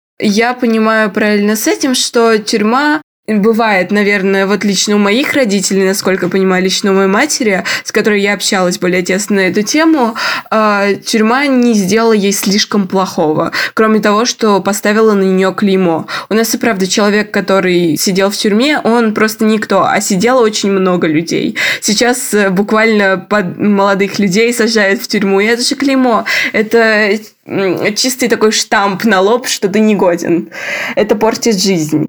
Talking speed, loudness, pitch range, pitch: 155 wpm, -11 LUFS, 195-230 Hz, 210 Hz